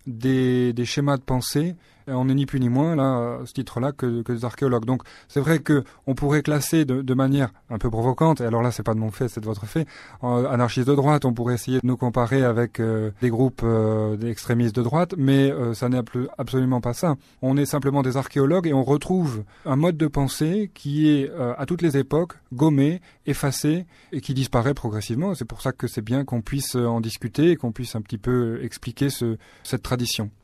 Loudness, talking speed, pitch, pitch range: -23 LUFS, 225 wpm, 130 Hz, 120-145 Hz